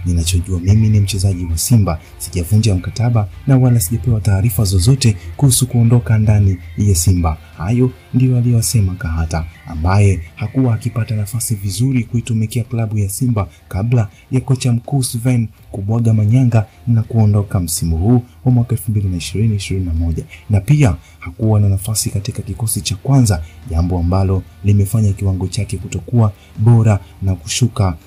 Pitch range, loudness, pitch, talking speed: 95-115 Hz, -16 LUFS, 105 Hz, 135 wpm